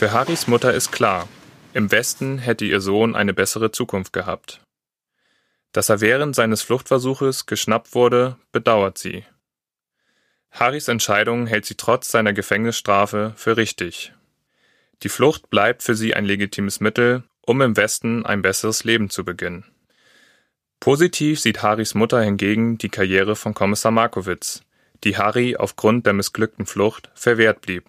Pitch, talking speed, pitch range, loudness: 110 Hz, 140 wpm, 105-120 Hz, -19 LUFS